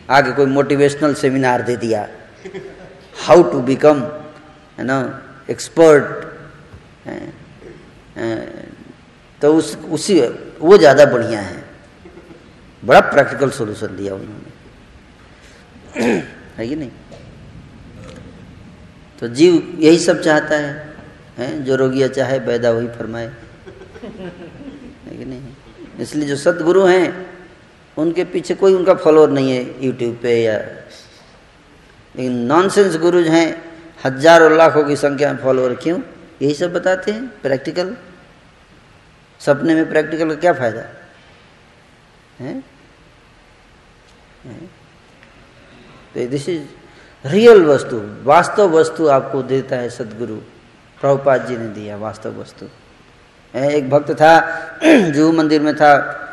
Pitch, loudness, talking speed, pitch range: 150 Hz, -14 LUFS, 110 wpm, 130-165 Hz